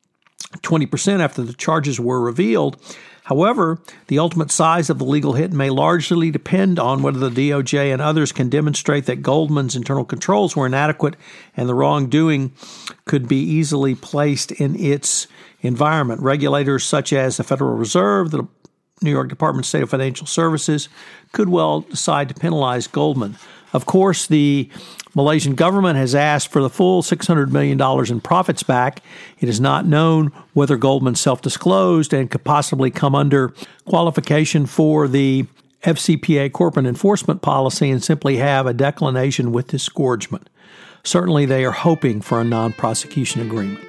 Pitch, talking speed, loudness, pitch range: 145 Hz, 155 wpm, -17 LUFS, 135-160 Hz